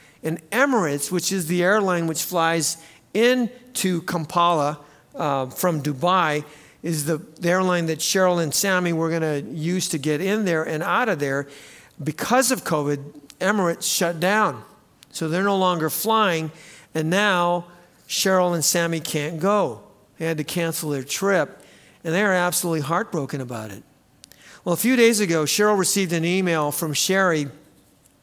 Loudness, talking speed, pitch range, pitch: -22 LUFS, 155 wpm, 155-185 Hz, 170 Hz